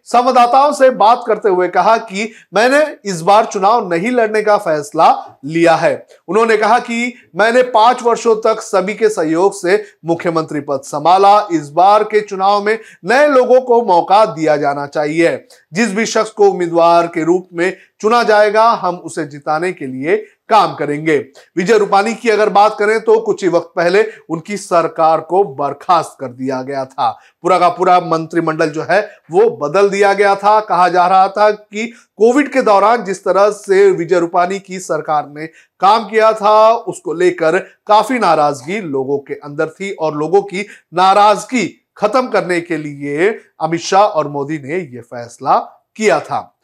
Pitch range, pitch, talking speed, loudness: 165-220 Hz, 195 Hz, 170 wpm, -13 LUFS